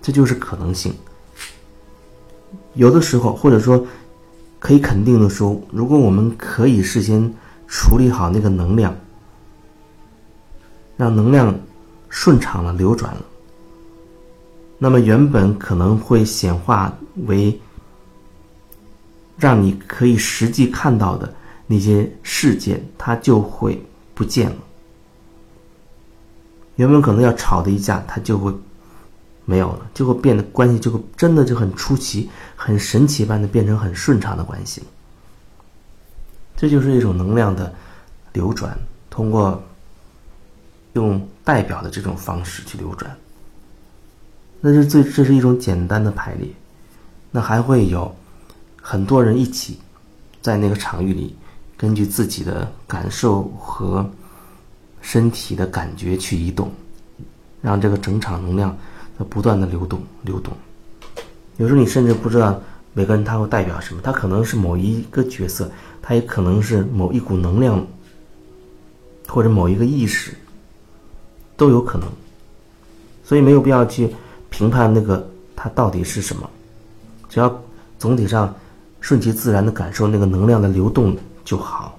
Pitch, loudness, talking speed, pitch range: 105 Hz, -17 LUFS, 205 characters per minute, 95-120 Hz